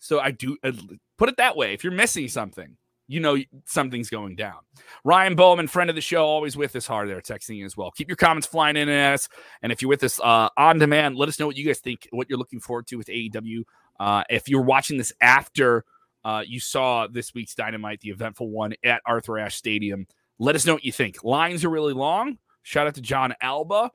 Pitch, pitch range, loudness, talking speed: 130 Hz, 115-150 Hz, -22 LUFS, 235 wpm